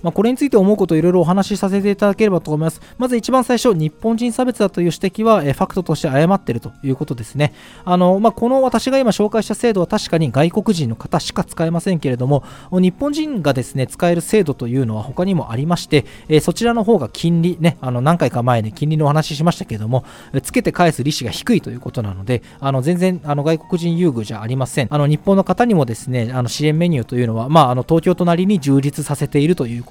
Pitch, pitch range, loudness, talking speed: 165 Hz, 135-195 Hz, -17 LUFS, 430 characters per minute